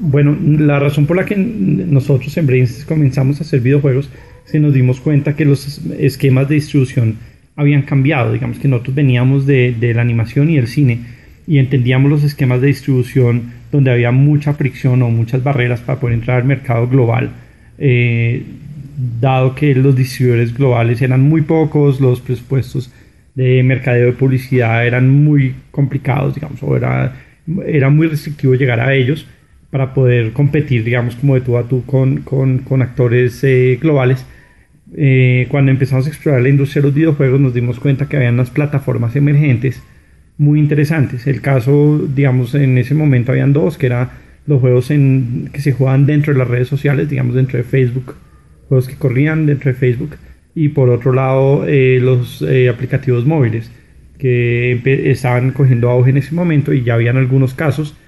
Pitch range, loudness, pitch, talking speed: 125-145 Hz, -13 LUFS, 135 Hz, 175 wpm